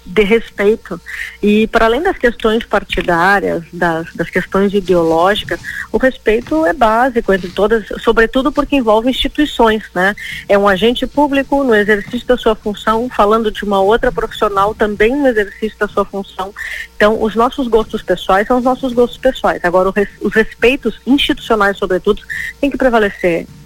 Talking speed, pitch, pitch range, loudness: 155 wpm, 220 Hz, 200-245 Hz, -14 LUFS